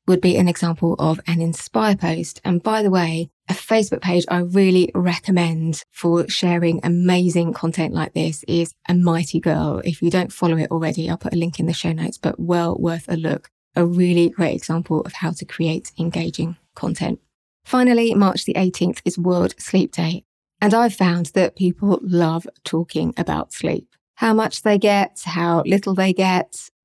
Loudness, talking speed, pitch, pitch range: -20 LUFS, 185 wpm, 175 Hz, 165-185 Hz